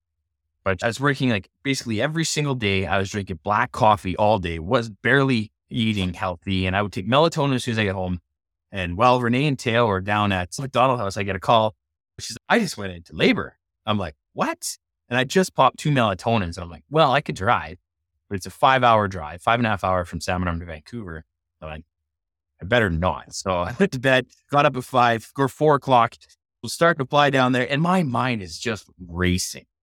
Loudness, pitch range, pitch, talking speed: -21 LUFS, 90-125 Hz, 105 Hz, 230 wpm